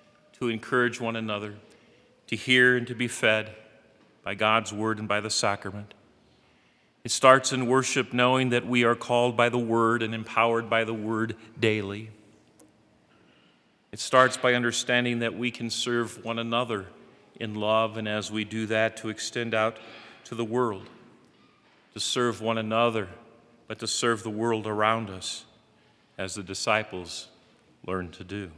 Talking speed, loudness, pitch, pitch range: 155 wpm, -26 LUFS, 115 Hz, 110-120 Hz